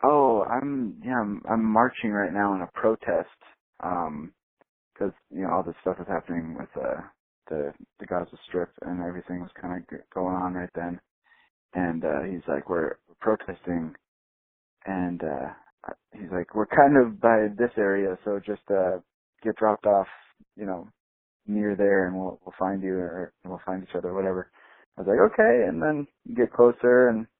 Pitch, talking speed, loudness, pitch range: 95 Hz, 180 wpm, -26 LUFS, 90-110 Hz